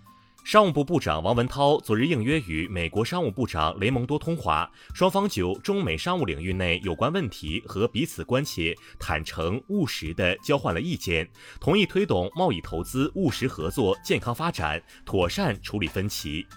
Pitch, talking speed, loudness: 115 Hz, 270 characters per minute, -26 LUFS